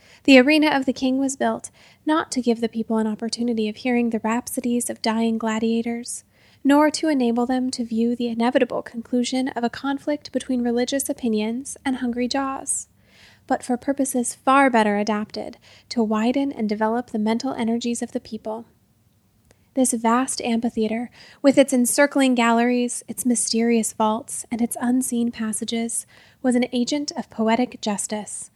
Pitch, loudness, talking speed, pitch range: 240 Hz, -22 LUFS, 160 wpm, 230-260 Hz